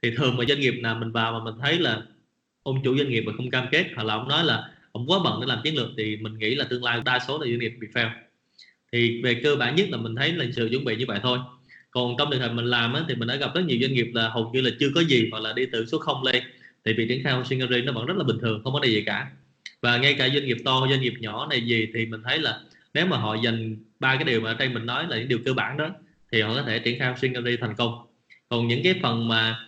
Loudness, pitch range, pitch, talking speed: -24 LUFS, 115-130 Hz, 120 Hz, 305 wpm